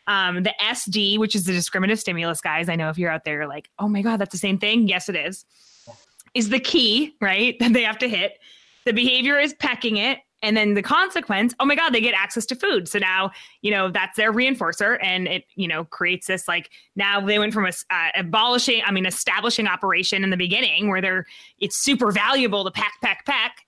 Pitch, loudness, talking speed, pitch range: 205 Hz, -20 LUFS, 230 wpm, 185-240 Hz